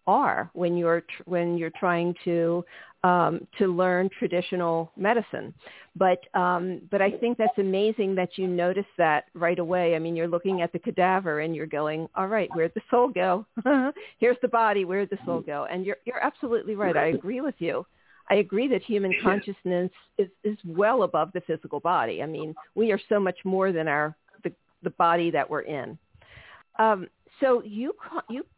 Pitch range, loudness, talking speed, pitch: 170-215 Hz, -26 LUFS, 185 wpm, 185 Hz